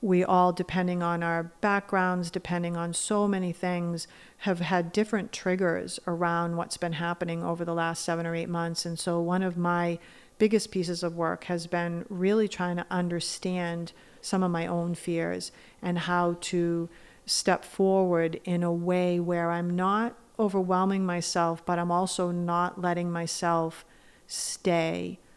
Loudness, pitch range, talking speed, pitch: -28 LUFS, 170-185 Hz, 155 wpm, 175 Hz